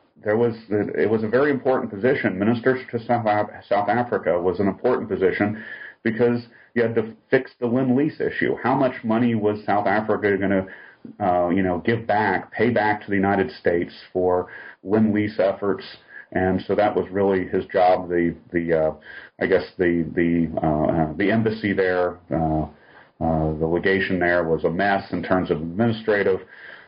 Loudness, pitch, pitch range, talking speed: -22 LUFS, 100 Hz, 90-115 Hz, 180 wpm